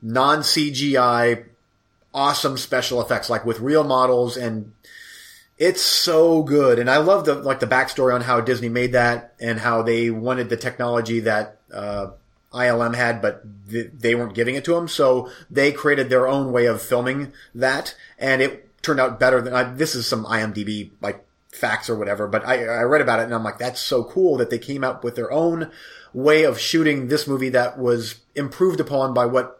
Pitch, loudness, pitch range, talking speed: 125 Hz, -20 LUFS, 115-140 Hz, 195 wpm